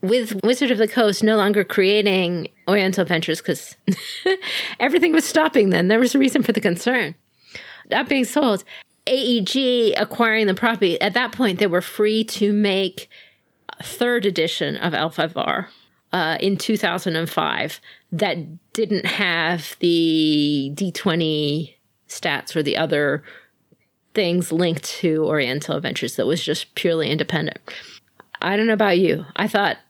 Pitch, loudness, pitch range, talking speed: 200 Hz, -20 LUFS, 170-230 Hz, 145 wpm